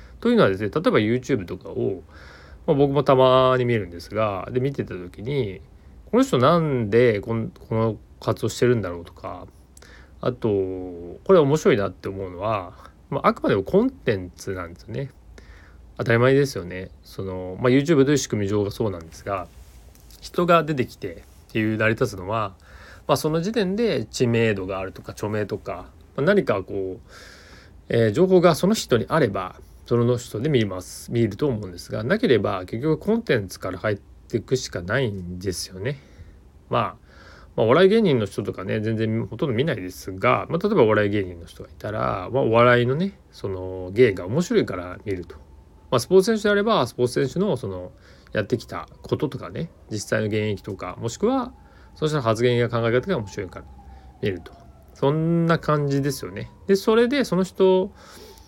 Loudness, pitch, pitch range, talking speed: -22 LUFS, 110 Hz, 90-135 Hz, 365 characters per minute